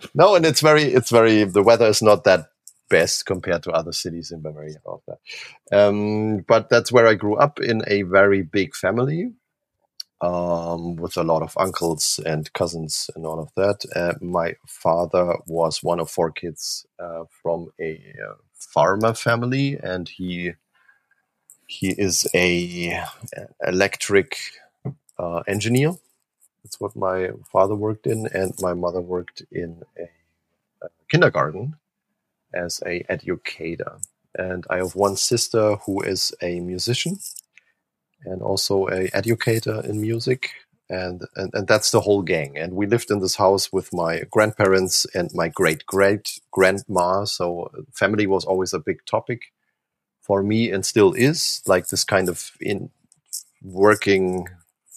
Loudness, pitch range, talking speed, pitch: -21 LUFS, 90-110 Hz, 145 wpm, 95 Hz